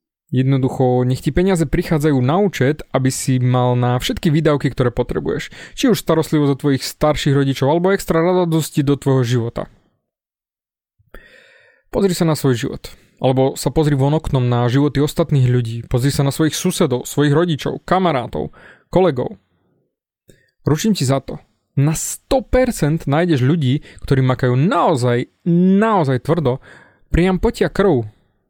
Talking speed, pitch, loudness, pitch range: 140 wpm, 145 Hz, -17 LUFS, 130-165 Hz